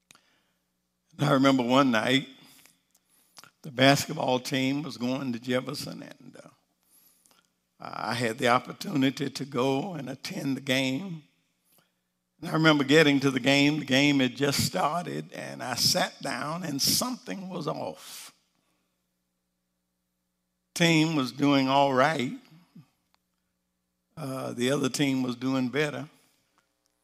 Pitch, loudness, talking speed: 130 Hz, -26 LUFS, 120 wpm